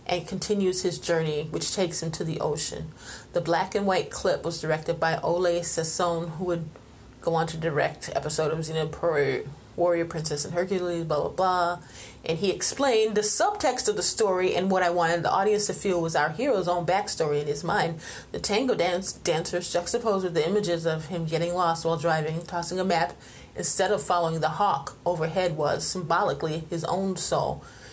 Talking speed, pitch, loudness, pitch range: 190 wpm, 170 Hz, -26 LUFS, 160-185 Hz